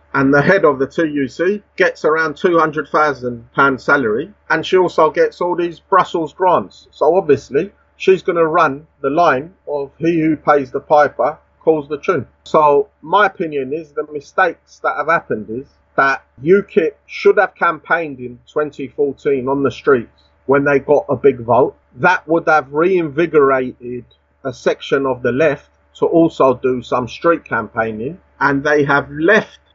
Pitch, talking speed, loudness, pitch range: 150 Hz, 160 wpm, -16 LUFS, 135-170 Hz